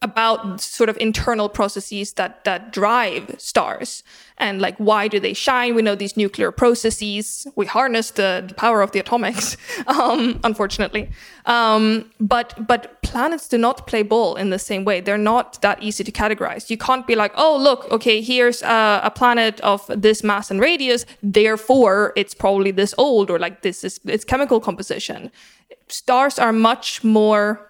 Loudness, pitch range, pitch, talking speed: -18 LUFS, 205-240 Hz, 220 Hz, 175 wpm